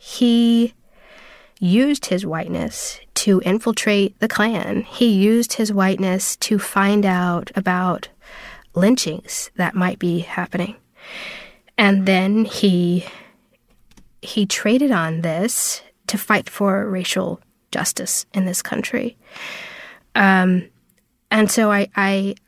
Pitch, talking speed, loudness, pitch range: 200 Hz, 110 wpm, -19 LUFS, 185-225 Hz